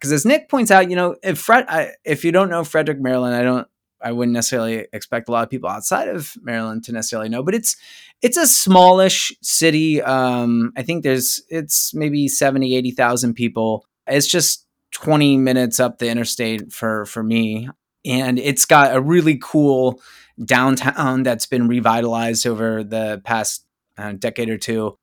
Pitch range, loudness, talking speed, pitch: 115-155 Hz, -17 LUFS, 175 wpm, 130 Hz